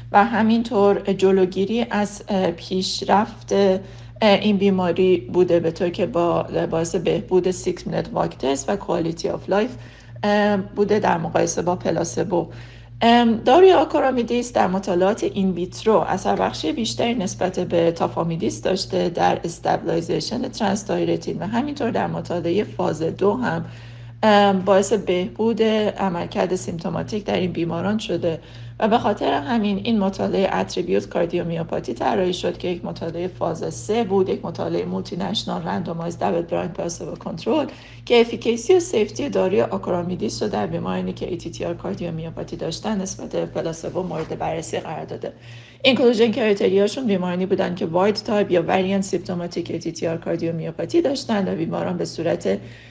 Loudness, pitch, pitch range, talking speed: -21 LUFS, 185 Hz, 165-210 Hz, 135 wpm